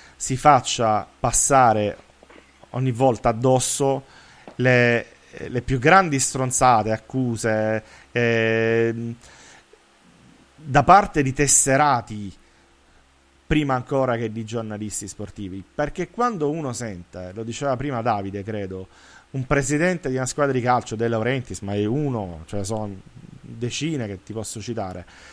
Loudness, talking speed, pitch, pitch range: -21 LUFS, 120 wpm, 115 Hz, 105-135 Hz